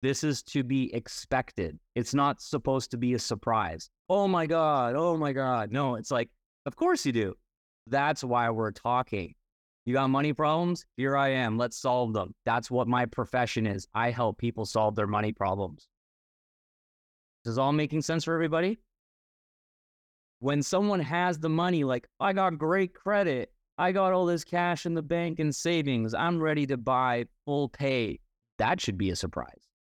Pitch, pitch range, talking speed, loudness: 135 Hz, 115-165 Hz, 180 wpm, -29 LUFS